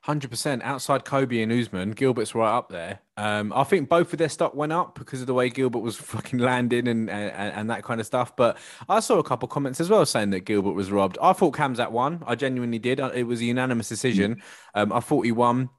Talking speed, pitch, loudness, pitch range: 245 wpm, 125 Hz, -24 LUFS, 115-135 Hz